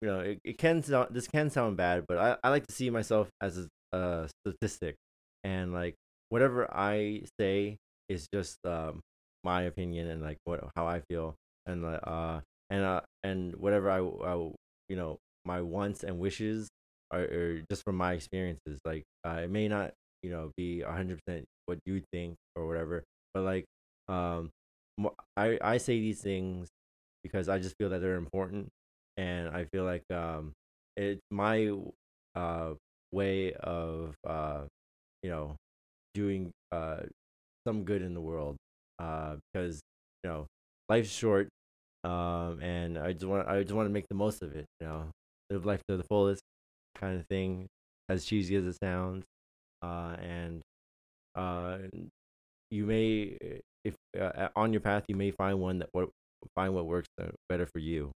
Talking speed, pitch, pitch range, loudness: 170 wpm, 90 Hz, 75-100 Hz, -35 LUFS